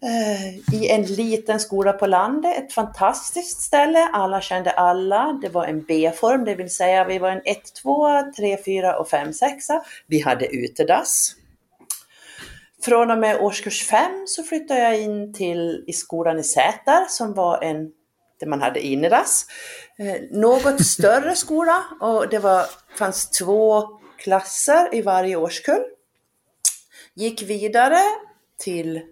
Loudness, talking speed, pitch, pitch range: -20 LUFS, 130 wpm, 210 Hz, 185-280 Hz